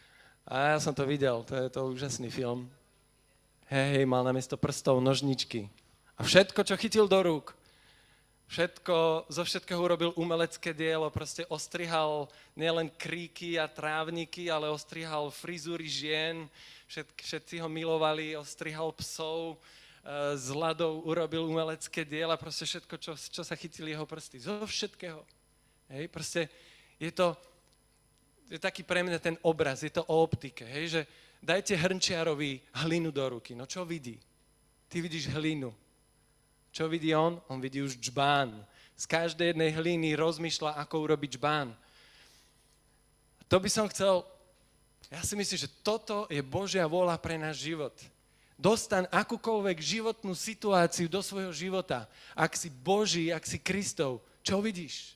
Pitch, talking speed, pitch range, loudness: 160 Hz, 145 wpm, 145-175 Hz, -32 LUFS